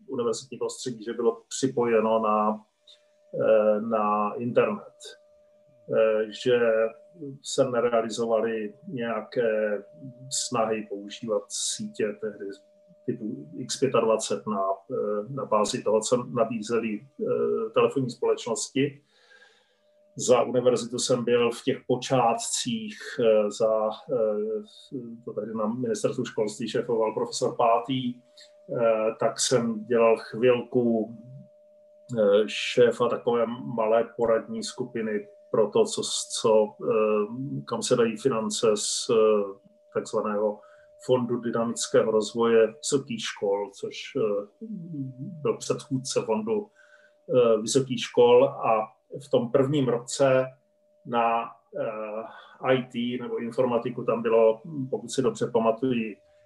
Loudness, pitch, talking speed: -26 LUFS, 125 Hz, 90 wpm